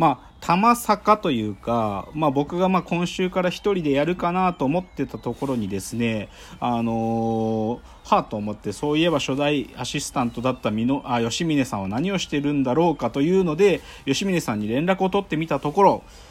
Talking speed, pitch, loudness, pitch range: 370 characters per minute, 145 Hz, -23 LUFS, 115-175 Hz